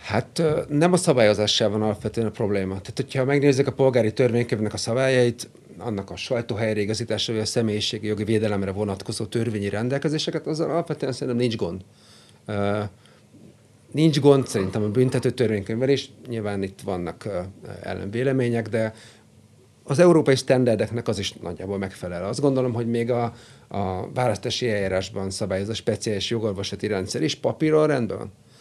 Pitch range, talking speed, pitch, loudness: 105-130 Hz, 145 wpm, 115 Hz, -23 LUFS